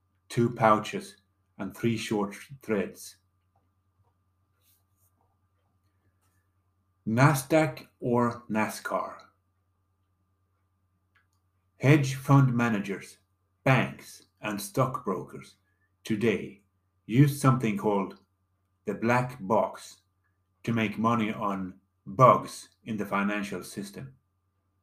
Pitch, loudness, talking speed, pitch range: 100 Hz, -27 LUFS, 75 wpm, 90-110 Hz